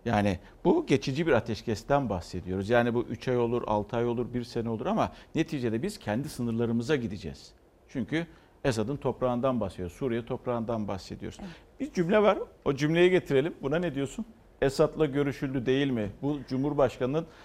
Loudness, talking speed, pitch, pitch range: -29 LUFS, 155 wpm, 125 Hz, 115-150 Hz